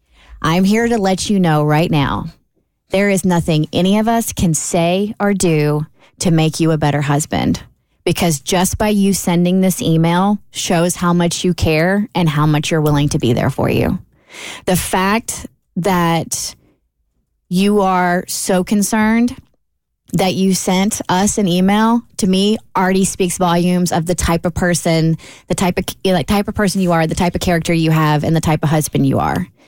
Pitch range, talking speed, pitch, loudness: 155-190 Hz, 185 wpm, 175 Hz, -15 LUFS